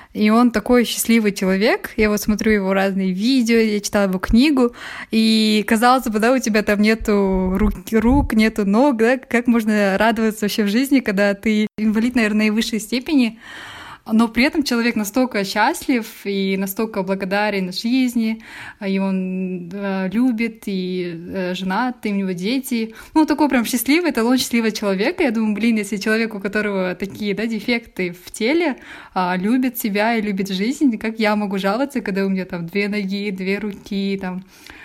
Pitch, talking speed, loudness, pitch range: 215 Hz, 165 wpm, -19 LUFS, 200-240 Hz